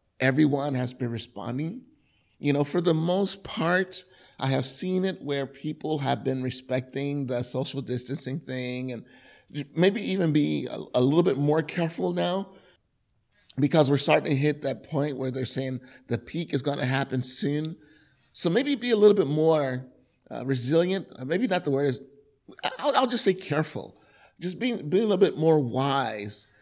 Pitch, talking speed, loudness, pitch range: 145 Hz, 175 wpm, -26 LUFS, 130-170 Hz